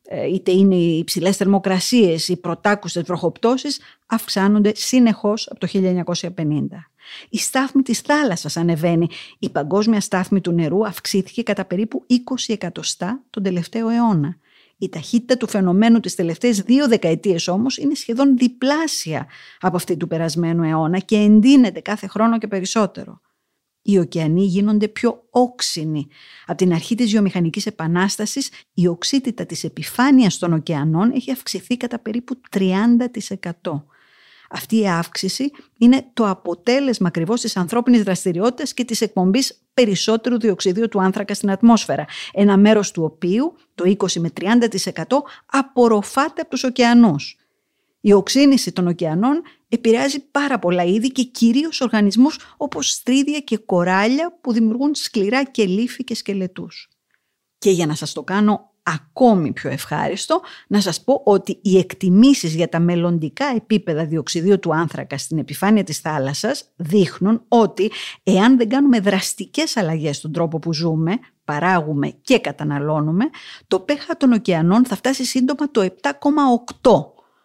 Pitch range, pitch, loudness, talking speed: 175-245 Hz, 205 Hz, -18 LUFS, 135 wpm